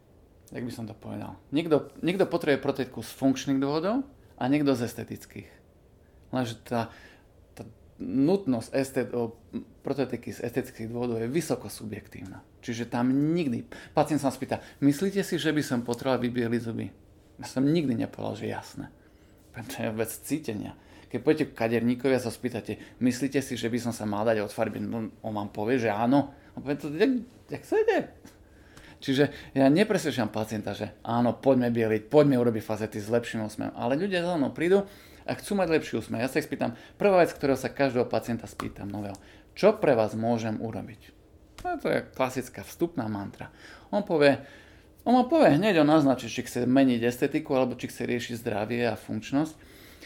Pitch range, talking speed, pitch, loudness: 110-140 Hz, 175 wpm, 120 Hz, -28 LUFS